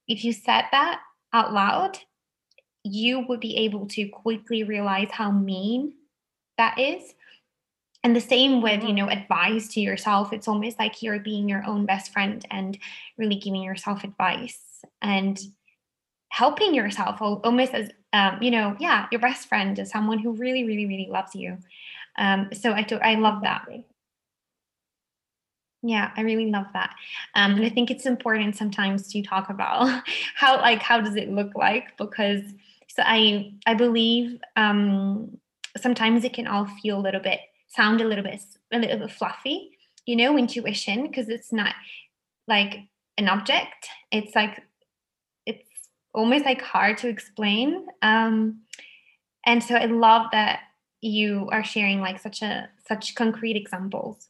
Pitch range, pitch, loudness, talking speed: 205-235 Hz, 220 Hz, -23 LUFS, 160 wpm